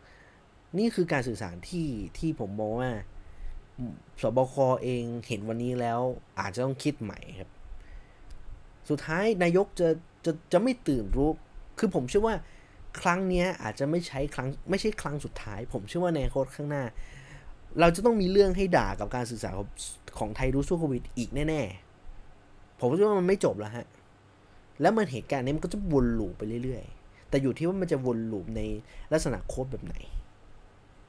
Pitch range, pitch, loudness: 105-160 Hz, 125 Hz, -29 LUFS